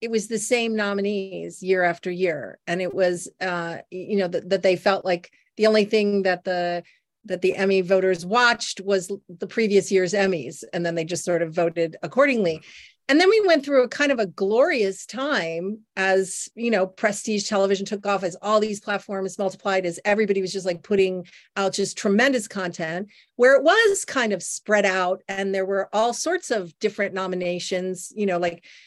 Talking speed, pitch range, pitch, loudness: 195 wpm, 185-215 Hz, 195 Hz, -23 LUFS